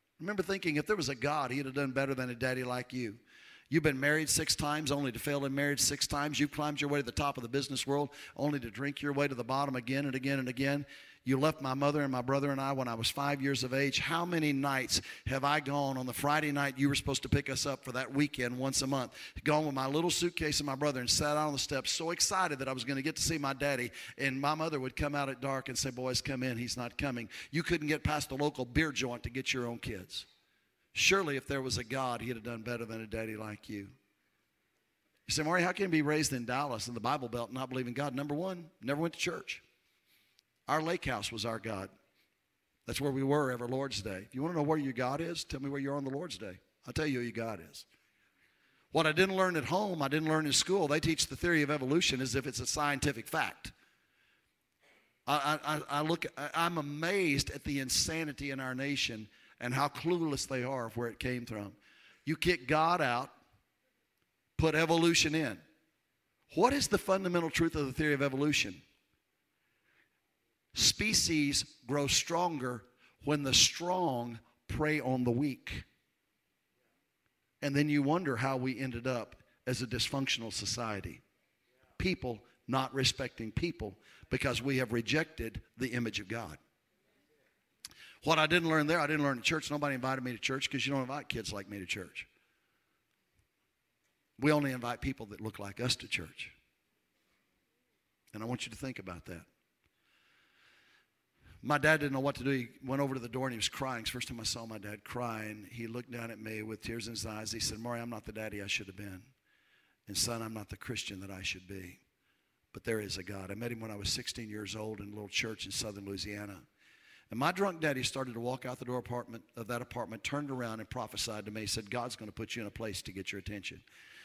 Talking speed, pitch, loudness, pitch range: 230 wpm, 130 Hz, -34 LUFS, 115-145 Hz